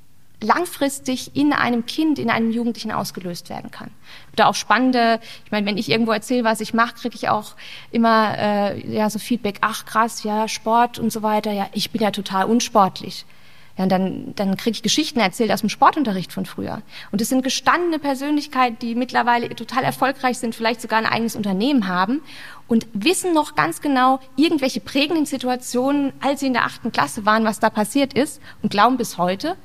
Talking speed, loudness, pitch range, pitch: 190 wpm, -20 LUFS, 210-260 Hz, 230 Hz